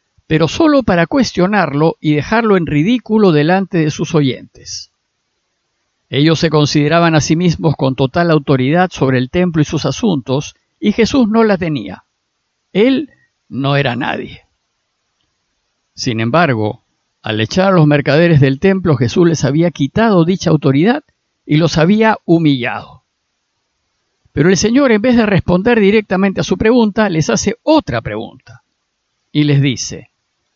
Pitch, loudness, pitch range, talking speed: 165 Hz, -13 LUFS, 140-195 Hz, 145 wpm